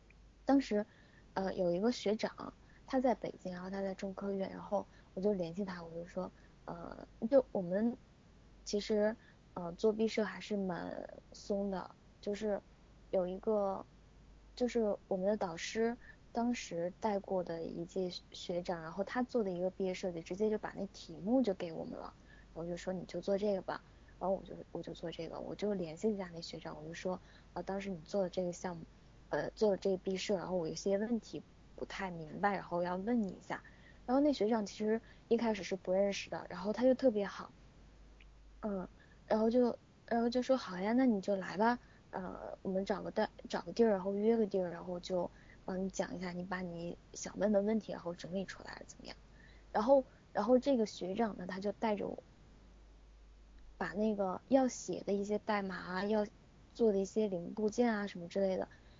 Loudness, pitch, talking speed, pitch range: -37 LUFS, 195 Hz, 275 characters per minute, 185-220 Hz